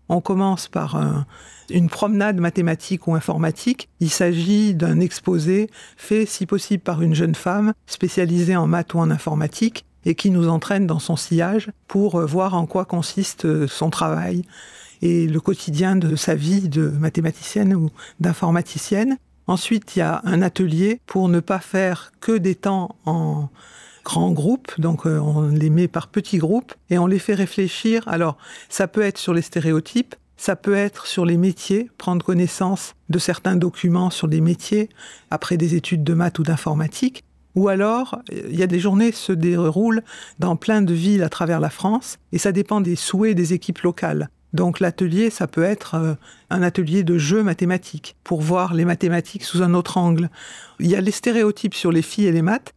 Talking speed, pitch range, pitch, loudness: 185 wpm, 165-200 Hz, 180 Hz, -20 LUFS